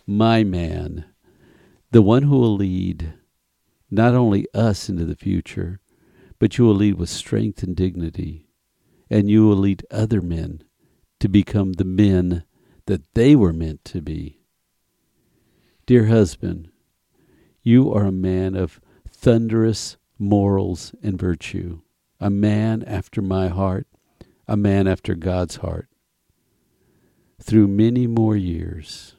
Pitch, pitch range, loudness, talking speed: 100 Hz, 90-110 Hz, -19 LUFS, 125 wpm